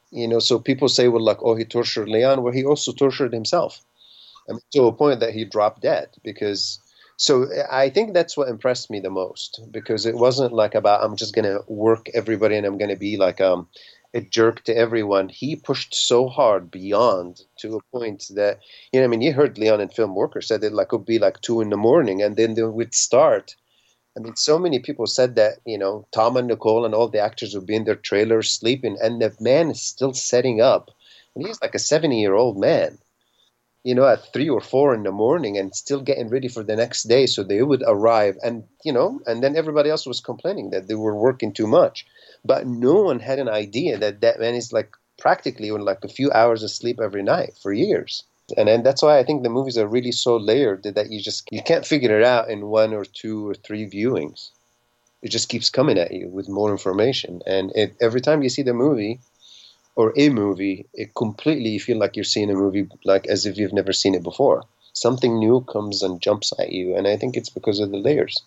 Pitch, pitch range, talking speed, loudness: 115 Hz, 105-125 Hz, 235 wpm, -20 LUFS